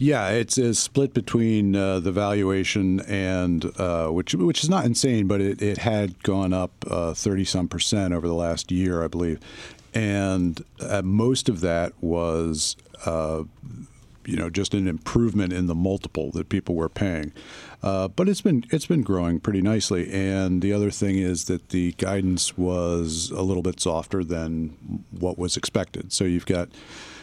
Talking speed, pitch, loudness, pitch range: 170 wpm, 95 Hz, -24 LUFS, 85-100 Hz